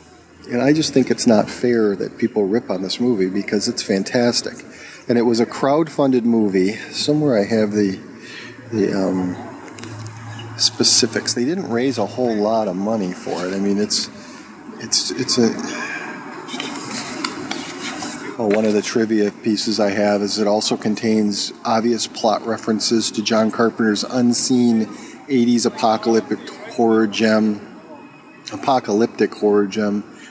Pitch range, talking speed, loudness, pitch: 105-120 Hz, 140 wpm, -19 LUFS, 110 Hz